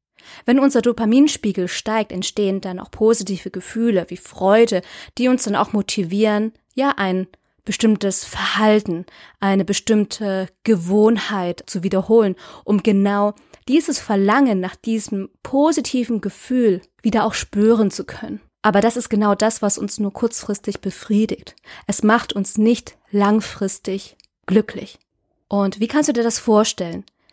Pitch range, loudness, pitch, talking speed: 195-230 Hz, -19 LUFS, 210 Hz, 135 wpm